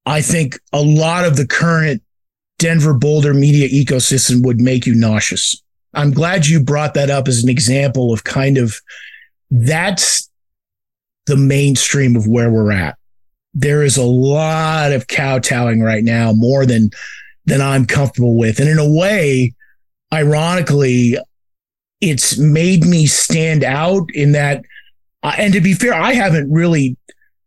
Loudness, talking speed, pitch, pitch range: -13 LUFS, 145 wpm, 140 Hz, 120-155 Hz